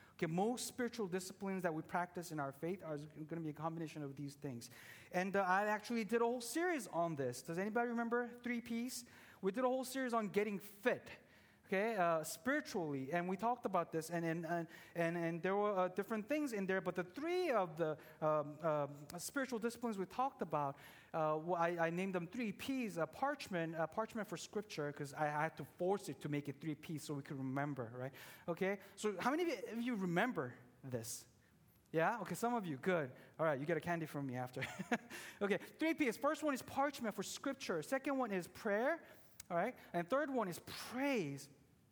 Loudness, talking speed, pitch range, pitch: -41 LUFS, 210 wpm, 155-230 Hz, 180 Hz